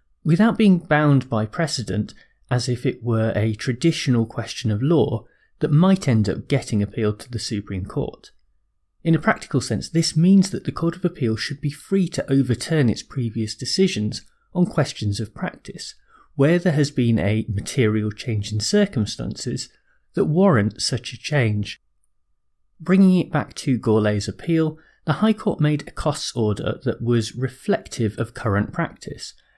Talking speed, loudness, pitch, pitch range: 160 wpm, -21 LUFS, 125 Hz, 110-160 Hz